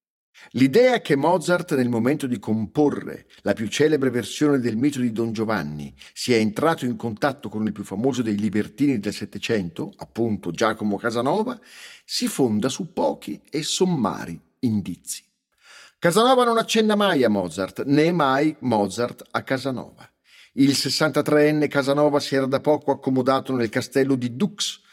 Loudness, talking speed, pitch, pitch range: -22 LUFS, 145 wpm, 135 Hz, 110-150 Hz